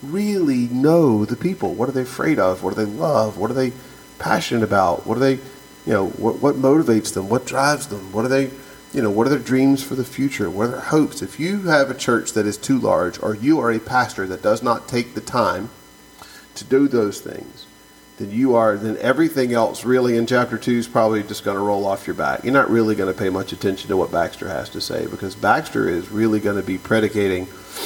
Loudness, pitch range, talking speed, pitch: -20 LUFS, 105-135 Hz, 240 wpm, 115 Hz